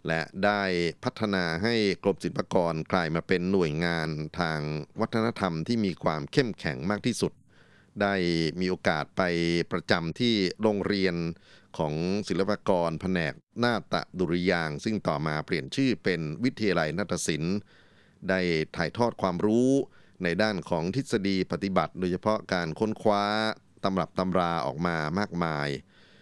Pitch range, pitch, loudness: 85-105 Hz, 95 Hz, -28 LUFS